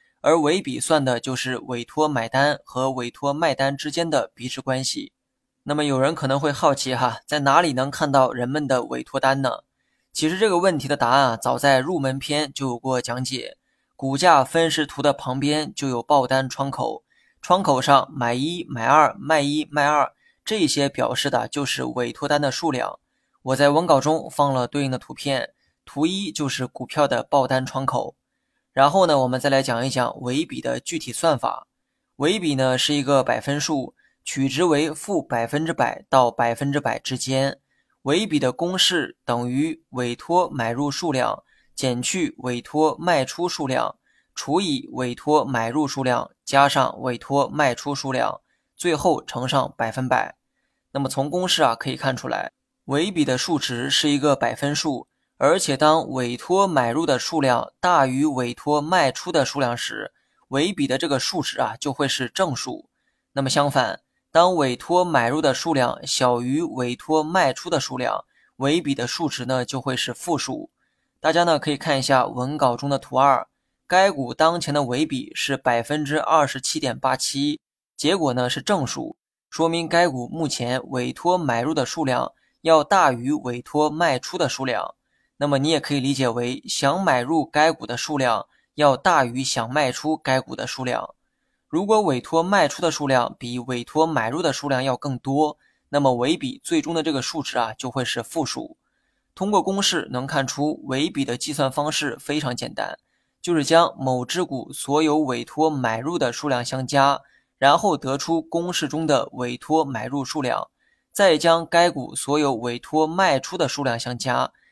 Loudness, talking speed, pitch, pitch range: -22 LUFS, 255 characters per minute, 140 Hz, 130-155 Hz